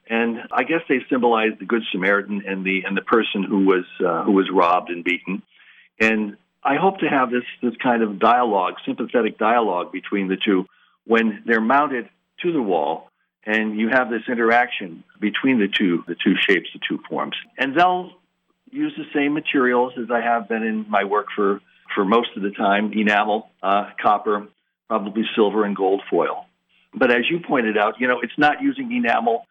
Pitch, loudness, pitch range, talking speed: 110 Hz, -20 LUFS, 100-125 Hz, 190 wpm